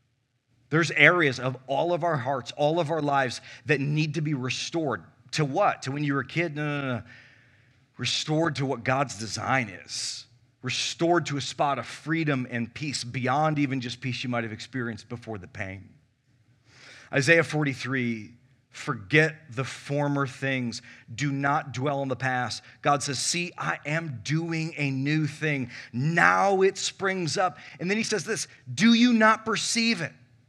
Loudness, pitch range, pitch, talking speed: -26 LUFS, 125-155 Hz, 135 Hz, 170 wpm